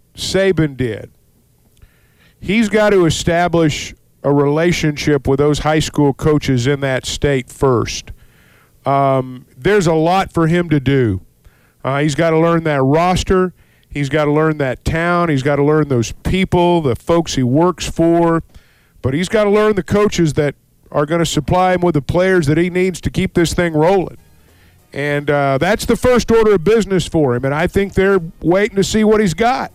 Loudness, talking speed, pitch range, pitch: -15 LUFS, 190 wpm, 140-185 Hz, 160 Hz